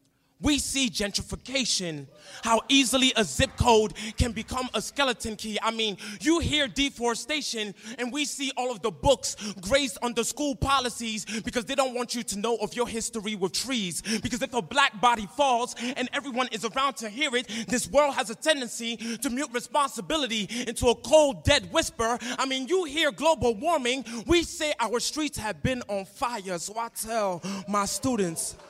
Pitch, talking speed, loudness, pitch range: 240 Hz, 180 wpm, -26 LUFS, 220-275 Hz